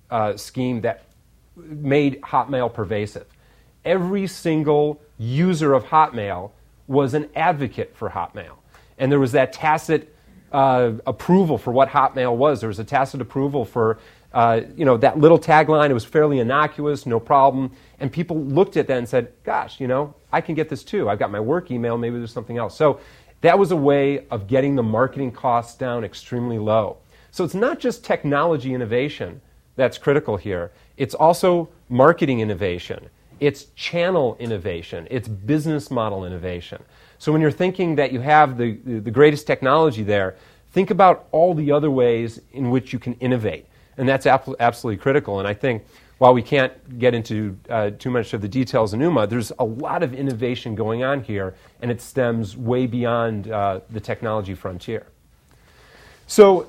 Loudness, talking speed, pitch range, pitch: -20 LUFS, 180 wpm, 115-150 Hz, 130 Hz